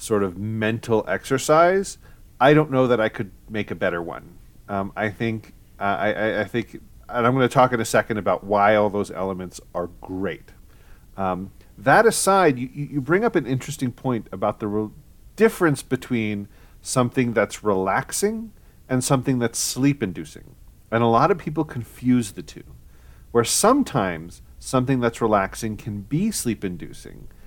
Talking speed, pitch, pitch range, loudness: 160 wpm, 115 Hz, 100-135 Hz, -22 LUFS